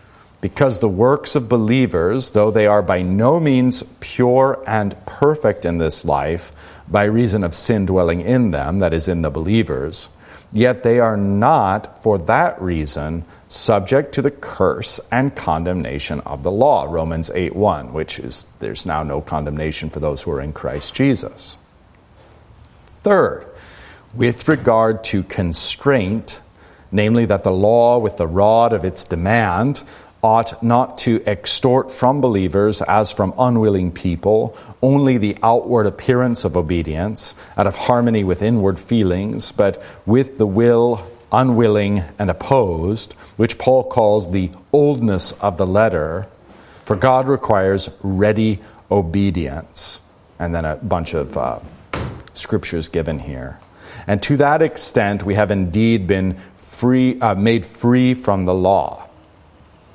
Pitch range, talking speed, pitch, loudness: 90-120 Hz, 140 wpm, 105 Hz, -17 LUFS